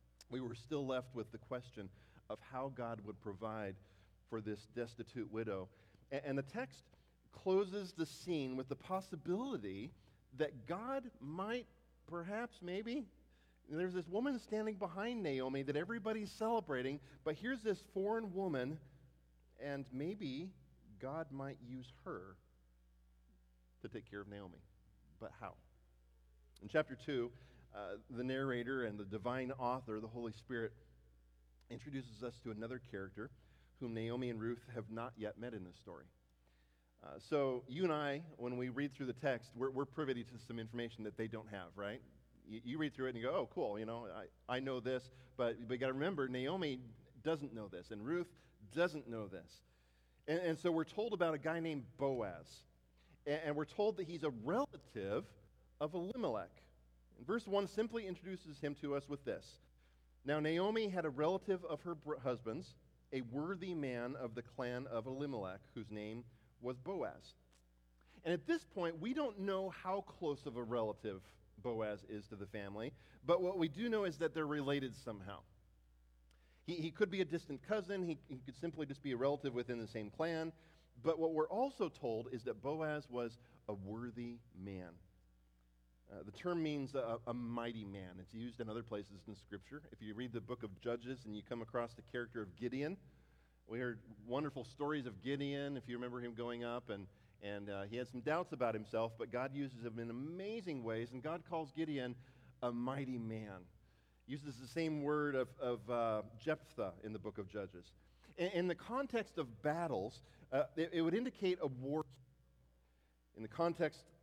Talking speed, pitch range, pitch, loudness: 180 wpm, 105-155 Hz, 125 Hz, -43 LUFS